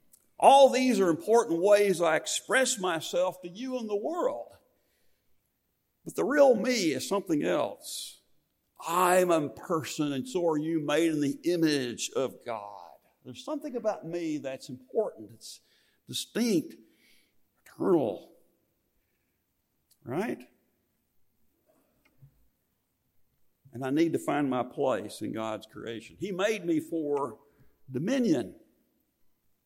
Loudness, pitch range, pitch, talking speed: -28 LUFS, 135-205 Hz, 165 Hz, 115 wpm